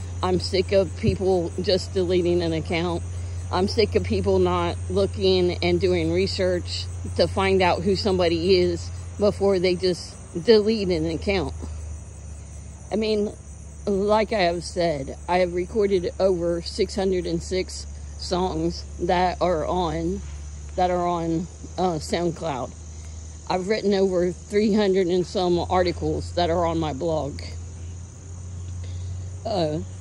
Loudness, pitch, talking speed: -23 LUFS, 100 Hz, 130 wpm